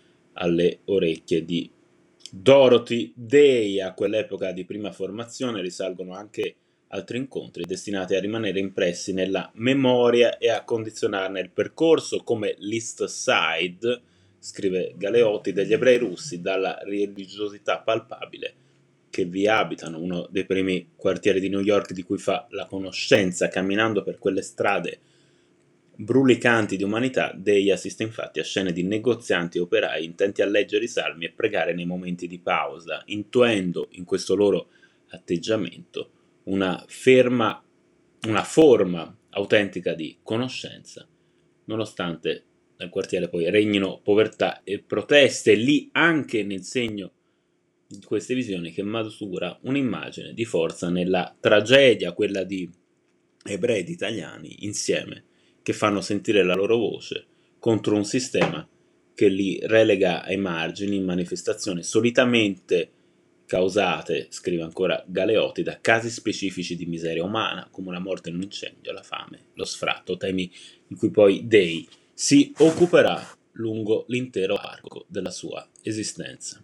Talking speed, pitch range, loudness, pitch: 130 wpm, 90-115 Hz, -23 LUFS, 100 Hz